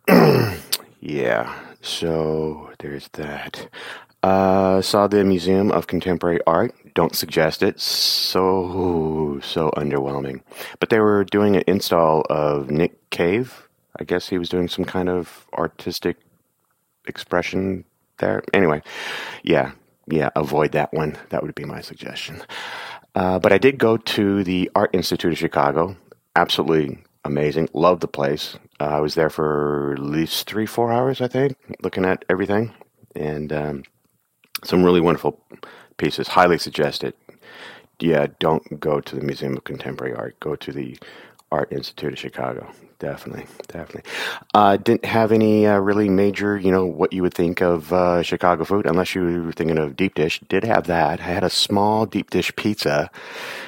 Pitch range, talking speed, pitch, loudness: 75-100 Hz, 155 wpm, 90 Hz, -20 LUFS